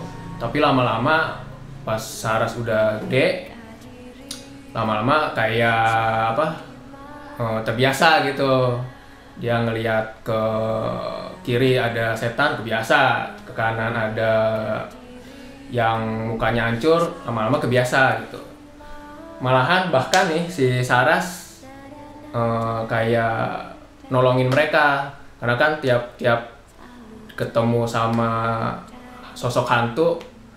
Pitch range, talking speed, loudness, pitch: 115-150 Hz, 80 wpm, -20 LUFS, 120 Hz